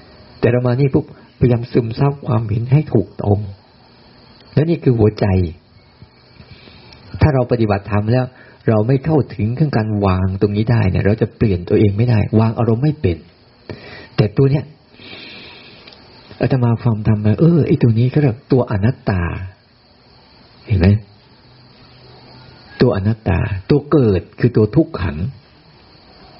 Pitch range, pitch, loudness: 105-130 Hz, 120 Hz, -16 LUFS